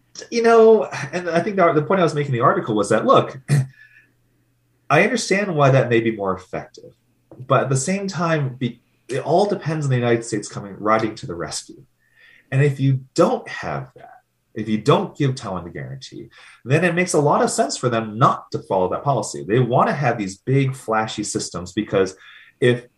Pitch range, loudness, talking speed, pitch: 115-170 Hz, -19 LUFS, 200 wpm, 135 Hz